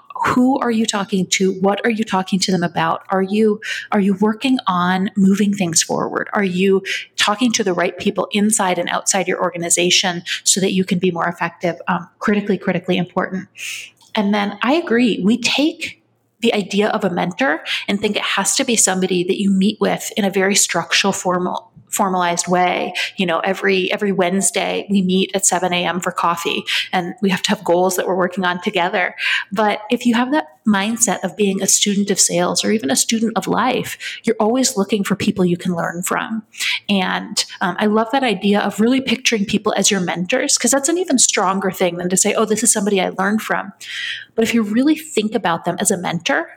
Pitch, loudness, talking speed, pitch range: 195 Hz, -17 LUFS, 210 wpm, 185-220 Hz